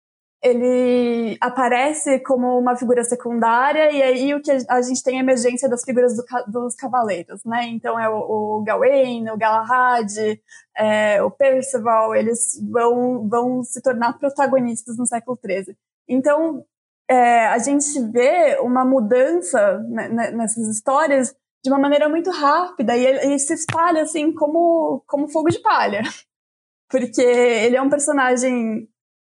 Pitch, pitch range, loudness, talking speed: 250 Hz, 235-275 Hz, -18 LUFS, 145 wpm